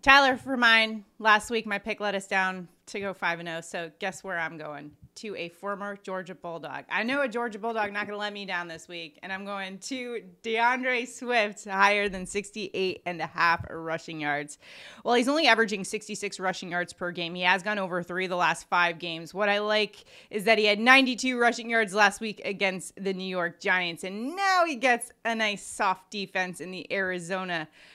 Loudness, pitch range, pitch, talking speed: -27 LUFS, 180-225 Hz, 200 Hz, 210 wpm